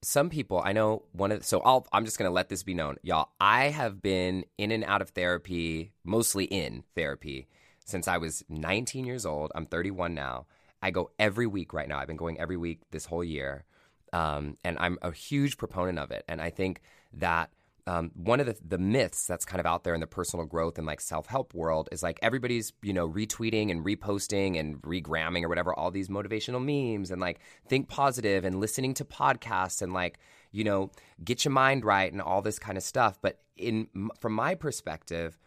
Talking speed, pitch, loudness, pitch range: 210 wpm, 95 Hz, -30 LUFS, 85-110 Hz